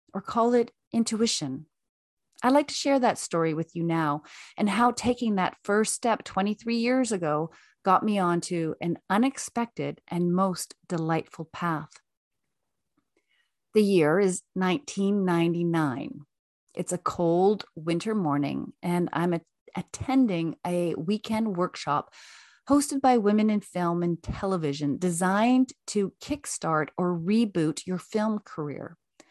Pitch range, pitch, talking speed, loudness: 170-225 Hz, 185 Hz, 125 wpm, -27 LUFS